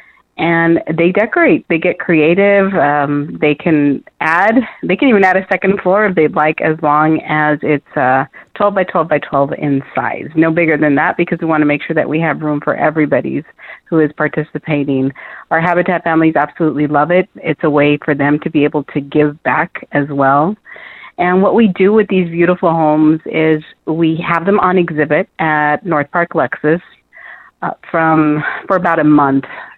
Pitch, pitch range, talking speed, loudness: 155 Hz, 150-175 Hz, 190 wpm, -13 LUFS